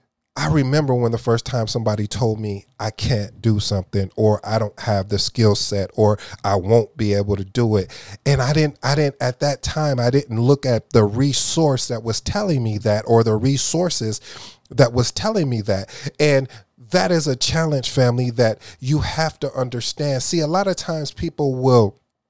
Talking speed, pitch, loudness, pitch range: 195 wpm, 120 Hz, -19 LUFS, 105-140 Hz